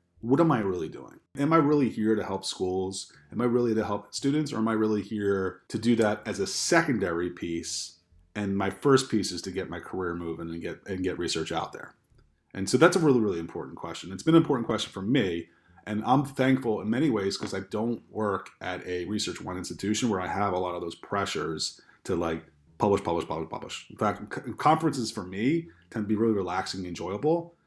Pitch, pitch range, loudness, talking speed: 100 Hz, 90-115 Hz, -28 LUFS, 225 wpm